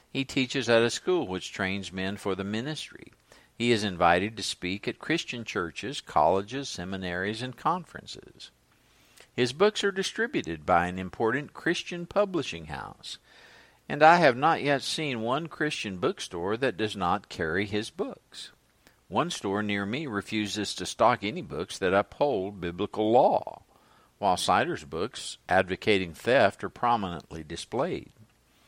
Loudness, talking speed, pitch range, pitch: -28 LUFS, 145 wpm, 95-135 Hz, 110 Hz